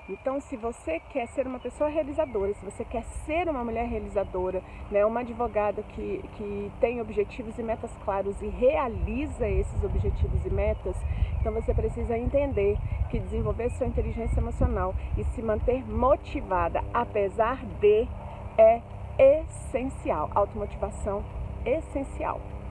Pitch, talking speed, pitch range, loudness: 225 Hz, 130 wpm, 200-270 Hz, -28 LUFS